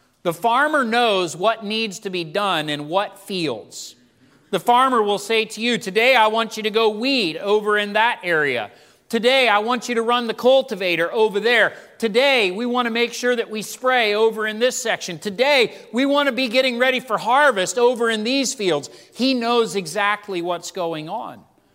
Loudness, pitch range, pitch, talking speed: -19 LUFS, 200-245 Hz, 225 Hz, 195 wpm